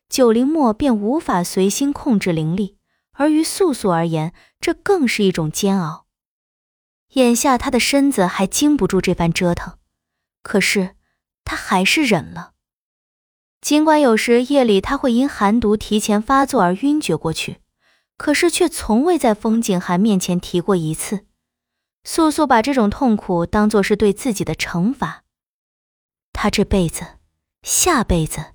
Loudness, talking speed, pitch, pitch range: -17 LUFS, 220 characters per minute, 210 Hz, 180-270 Hz